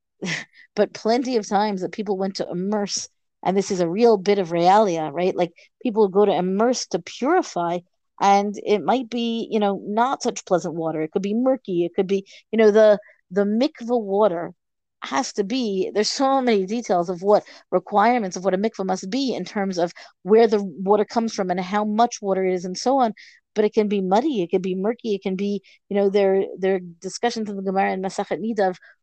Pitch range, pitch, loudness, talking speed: 190-225 Hz, 200 Hz, -22 LUFS, 215 wpm